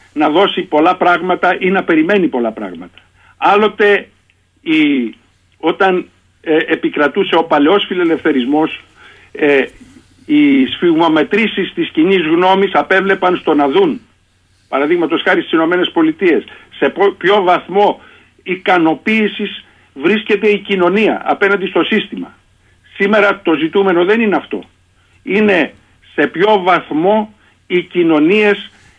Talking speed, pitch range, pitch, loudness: 110 wpm, 175-215 Hz, 195 Hz, -13 LUFS